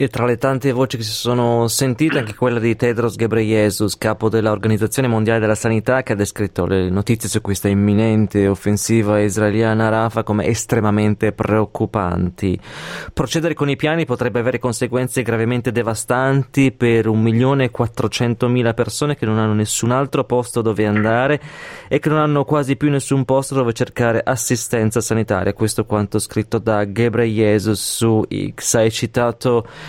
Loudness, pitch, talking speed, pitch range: -18 LUFS, 115 Hz, 150 wpm, 110-125 Hz